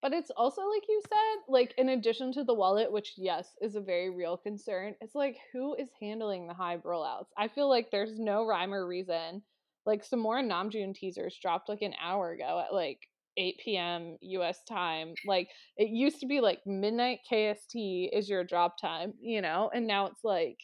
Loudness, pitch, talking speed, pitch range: -33 LUFS, 210 Hz, 200 wpm, 185-250 Hz